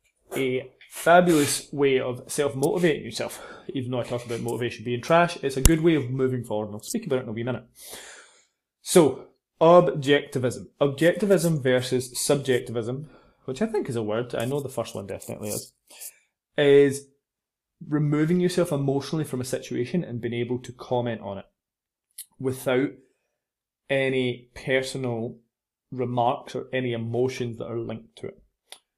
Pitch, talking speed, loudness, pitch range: 130 Hz, 155 wpm, -25 LUFS, 120-145 Hz